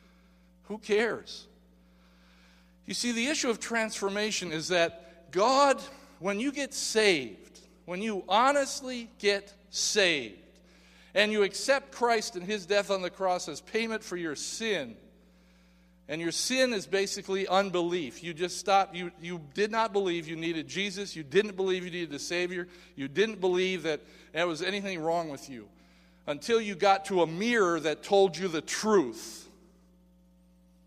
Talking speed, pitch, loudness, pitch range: 155 wpm, 185 Hz, -29 LUFS, 160-210 Hz